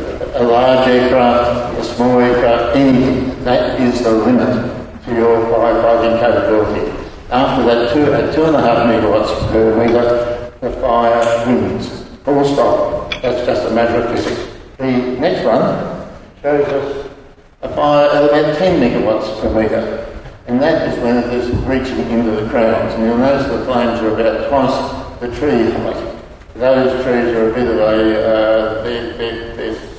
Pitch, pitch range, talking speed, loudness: 120 Hz, 115-130 Hz, 165 wpm, -14 LUFS